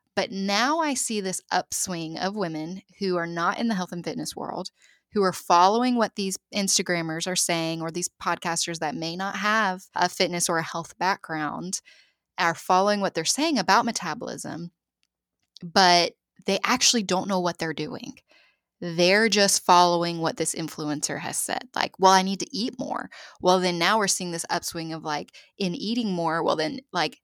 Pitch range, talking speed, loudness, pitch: 165-195 Hz, 185 wpm, -24 LUFS, 180 Hz